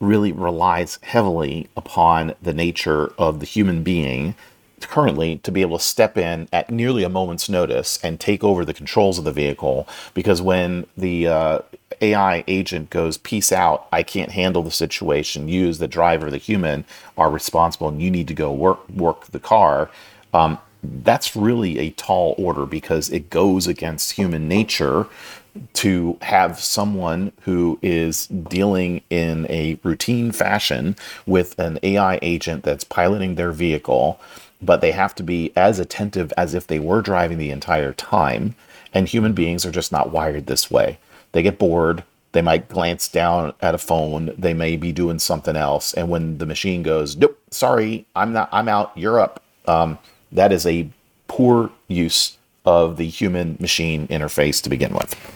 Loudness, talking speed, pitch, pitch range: -19 LUFS, 170 wpm, 85 Hz, 80-95 Hz